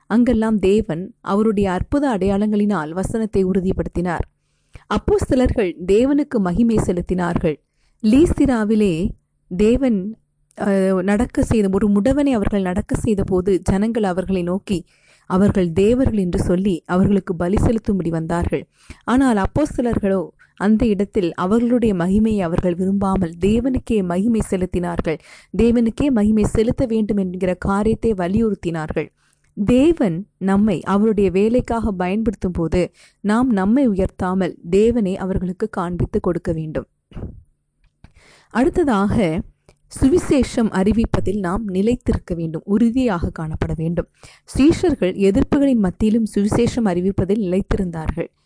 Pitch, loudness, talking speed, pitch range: 200 Hz, -19 LUFS, 95 wpm, 185-225 Hz